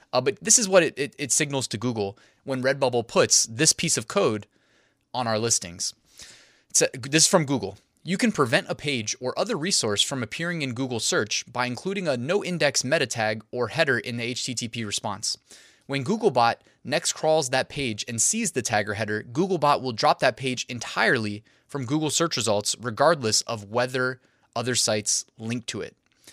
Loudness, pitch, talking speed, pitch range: -24 LUFS, 130 Hz, 185 wpm, 115-155 Hz